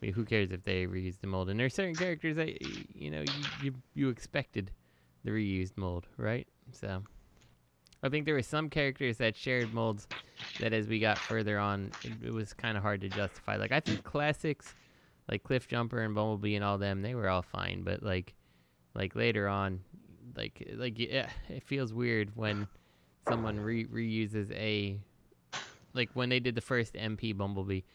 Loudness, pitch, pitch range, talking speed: -35 LUFS, 110 Hz, 100-125 Hz, 190 wpm